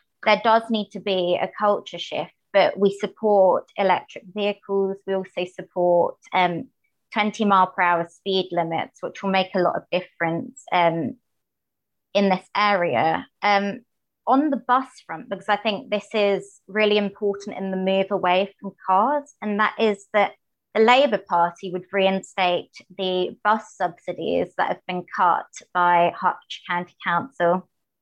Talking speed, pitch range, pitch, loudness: 155 wpm, 180-210 Hz, 195 Hz, -22 LUFS